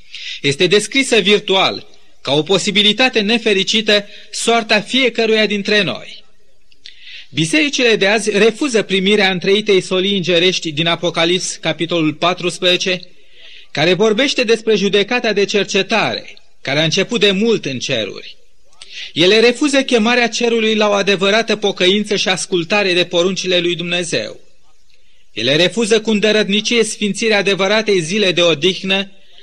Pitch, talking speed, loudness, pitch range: 205 Hz, 120 wpm, -14 LUFS, 180-220 Hz